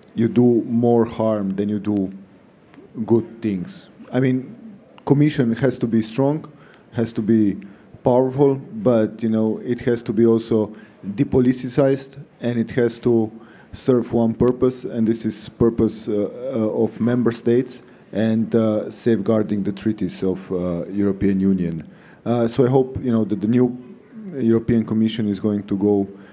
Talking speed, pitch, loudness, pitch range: 155 wpm, 115 Hz, -20 LUFS, 105-125 Hz